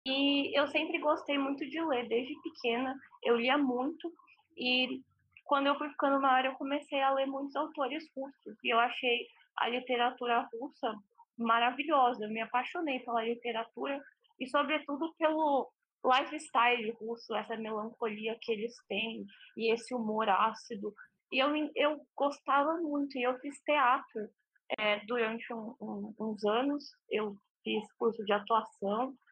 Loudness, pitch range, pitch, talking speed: -33 LUFS, 230-290 Hz, 255 Hz, 145 wpm